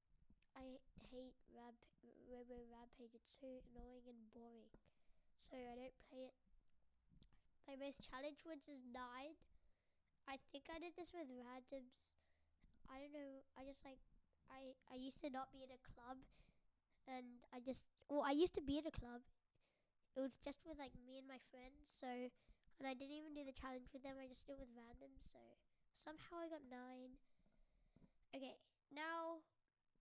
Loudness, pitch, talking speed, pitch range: -54 LUFS, 265 Hz, 175 wpm, 250-280 Hz